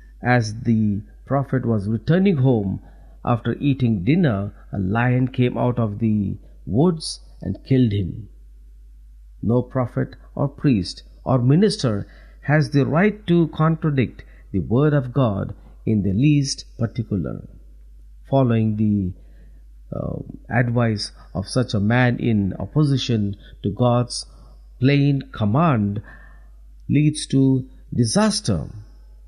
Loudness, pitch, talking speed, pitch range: -21 LUFS, 115 Hz, 115 wpm, 100-135 Hz